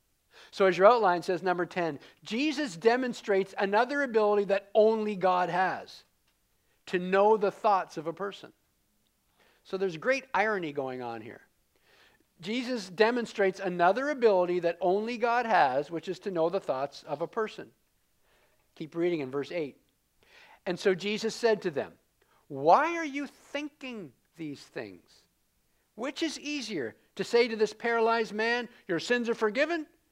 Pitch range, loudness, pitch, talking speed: 180-235 Hz, -29 LUFS, 205 Hz, 150 wpm